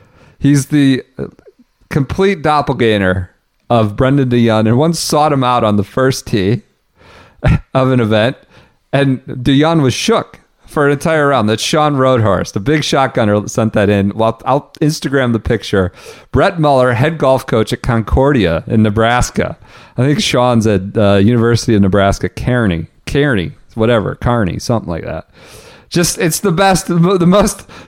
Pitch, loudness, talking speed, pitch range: 125 Hz, -13 LUFS, 155 wpm, 110-145 Hz